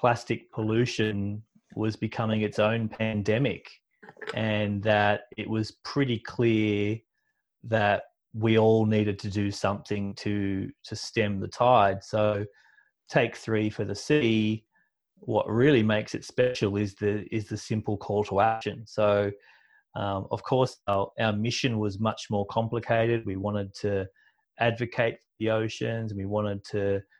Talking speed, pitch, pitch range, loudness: 145 wpm, 110 Hz, 105-115 Hz, -27 LUFS